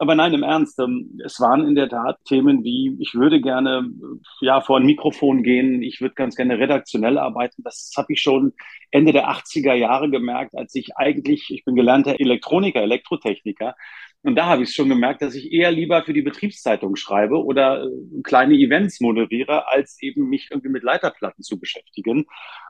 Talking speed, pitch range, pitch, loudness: 180 wpm, 130-205 Hz, 140 Hz, -19 LUFS